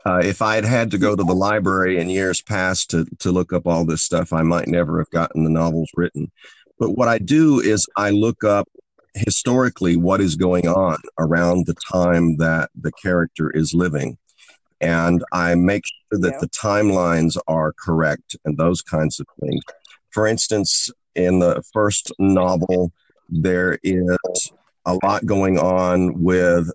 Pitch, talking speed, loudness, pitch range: 90 Hz, 170 wpm, -19 LUFS, 85-95 Hz